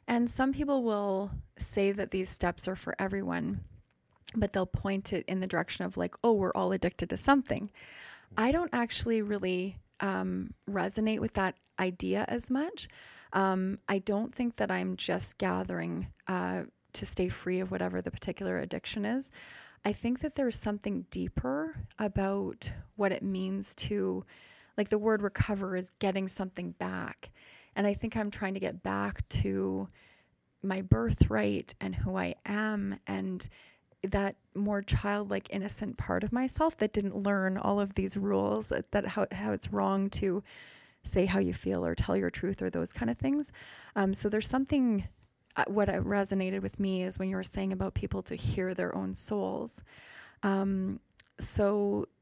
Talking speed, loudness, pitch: 170 wpm, -32 LUFS, 195 Hz